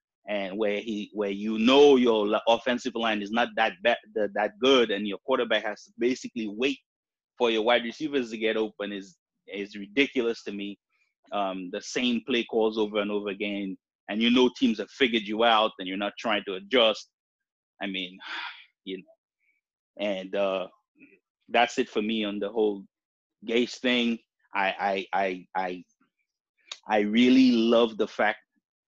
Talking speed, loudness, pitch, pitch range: 170 wpm, -26 LUFS, 110 Hz, 100-120 Hz